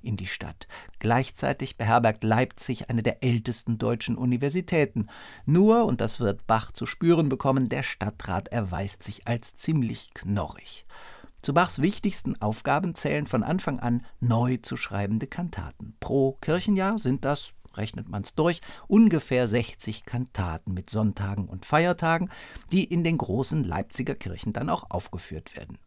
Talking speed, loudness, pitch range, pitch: 145 wpm, -27 LUFS, 105-150 Hz, 120 Hz